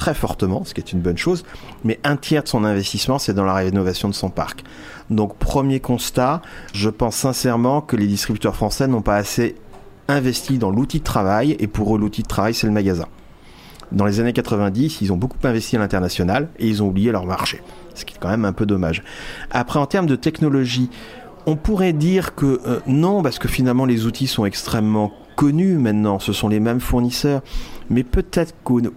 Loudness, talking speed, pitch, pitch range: -19 LUFS, 205 wpm, 115 Hz, 105-135 Hz